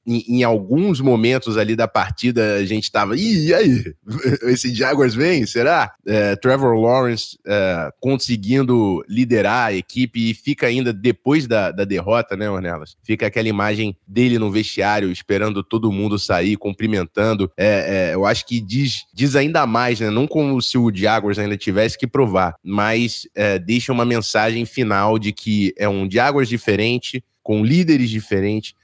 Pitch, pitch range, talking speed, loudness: 115 Hz, 105-125 Hz, 165 wpm, -18 LUFS